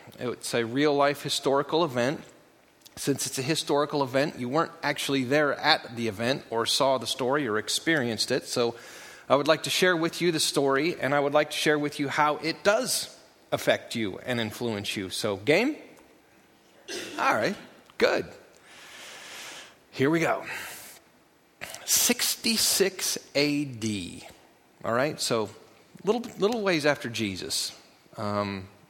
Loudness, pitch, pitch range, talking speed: -26 LUFS, 145 Hz, 120-160 Hz, 145 wpm